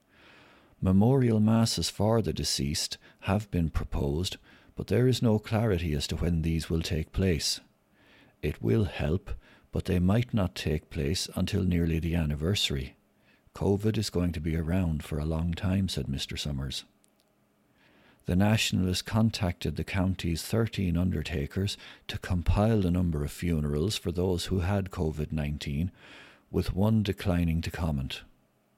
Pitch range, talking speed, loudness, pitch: 80-100 Hz, 145 wpm, -29 LUFS, 90 Hz